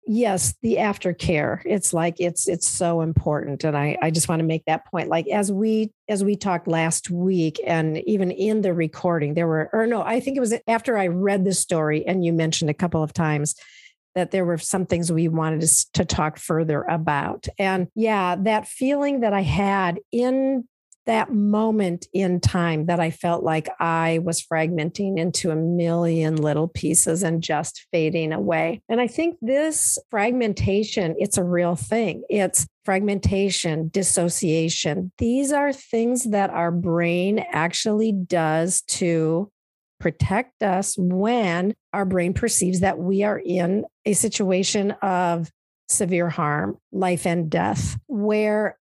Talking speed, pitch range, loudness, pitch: 160 wpm, 165-210 Hz, -22 LUFS, 180 Hz